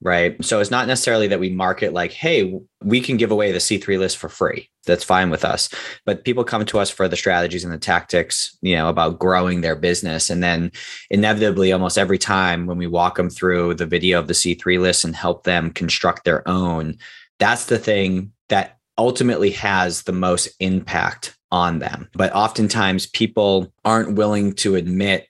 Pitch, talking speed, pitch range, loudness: 95 Hz, 190 wpm, 90-105 Hz, -19 LUFS